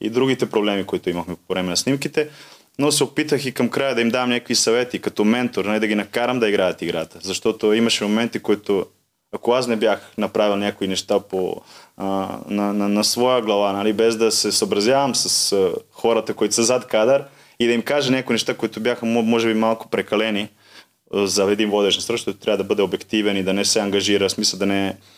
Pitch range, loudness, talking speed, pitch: 100-125 Hz, -20 LUFS, 205 wpm, 110 Hz